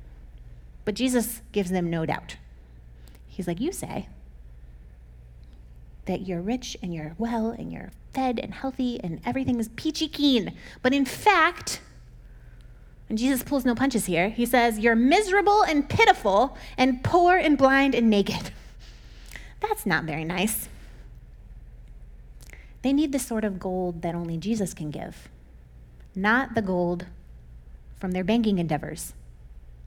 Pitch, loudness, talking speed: 185 Hz, -25 LUFS, 140 wpm